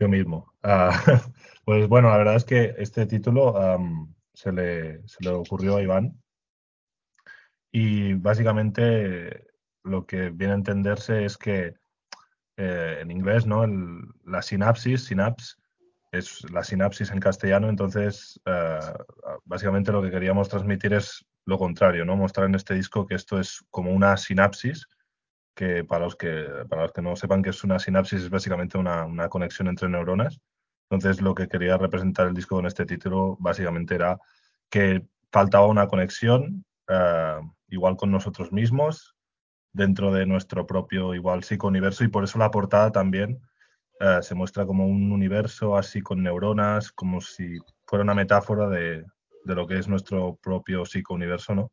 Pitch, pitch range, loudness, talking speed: 95 Hz, 90-105 Hz, -24 LUFS, 160 wpm